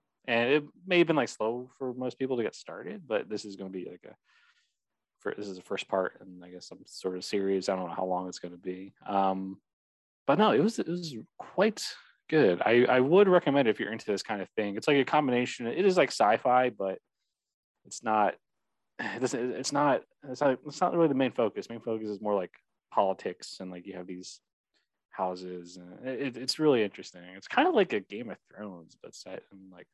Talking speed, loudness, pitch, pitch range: 235 wpm, -29 LUFS, 105 Hz, 95-125 Hz